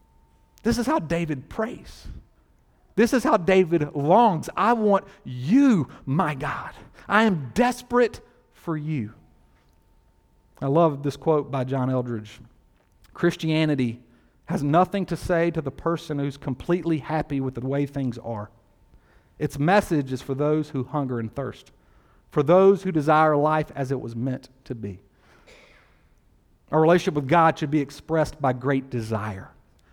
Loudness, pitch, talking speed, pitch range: -23 LUFS, 145 Hz, 145 wpm, 120-170 Hz